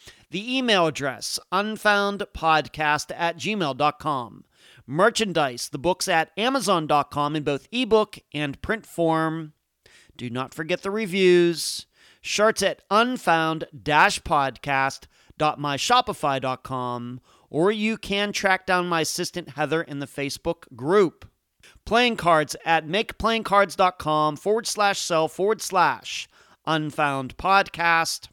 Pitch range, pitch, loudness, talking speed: 150-200 Hz, 165 Hz, -23 LUFS, 100 wpm